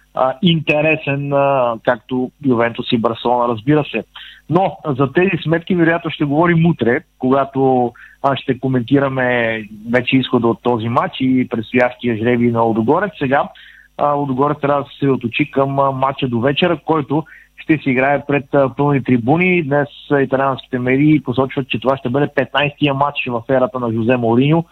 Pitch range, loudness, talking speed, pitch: 125-145 Hz, -16 LUFS, 150 wpm, 135 Hz